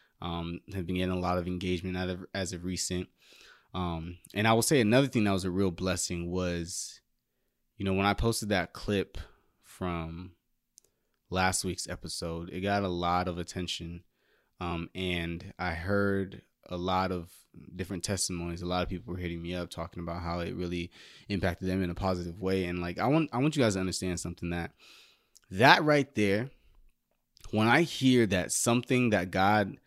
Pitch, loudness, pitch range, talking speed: 90 Hz, -30 LUFS, 85-100 Hz, 185 wpm